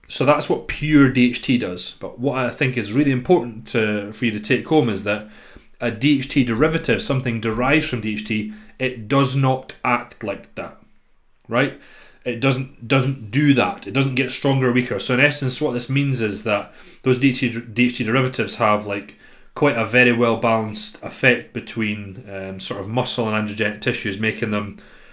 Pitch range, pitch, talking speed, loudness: 110-135 Hz, 125 Hz, 180 wpm, -20 LUFS